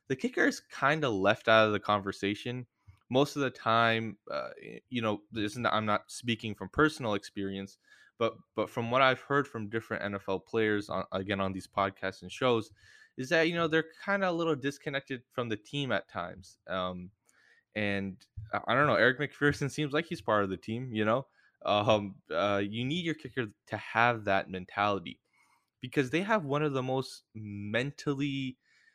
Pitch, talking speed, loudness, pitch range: 115 Hz, 190 wpm, -31 LUFS, 100-135 Hz